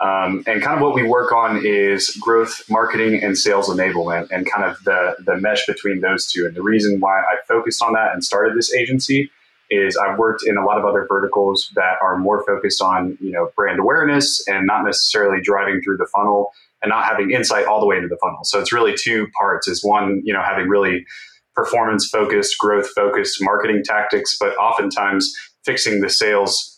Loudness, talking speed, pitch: -17 LUFS, 205 wpm, 110 Hz